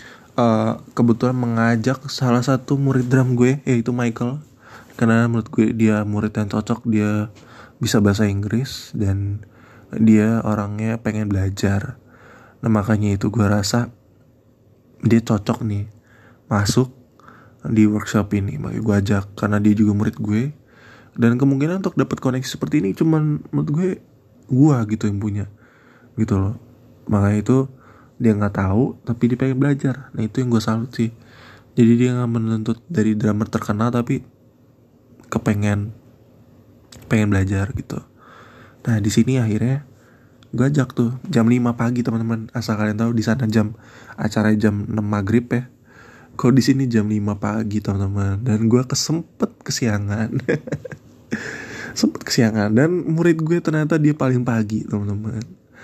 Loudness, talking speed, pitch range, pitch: -20 LUFS, 145 wpm, 105-125 Hz, 115 Hz